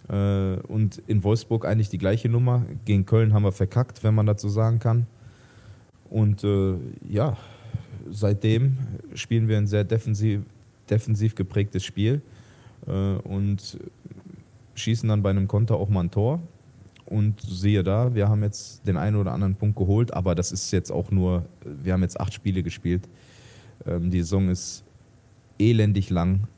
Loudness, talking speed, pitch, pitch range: -24 LUFS, 155 wpm, 105 Hz, 95-115 Hz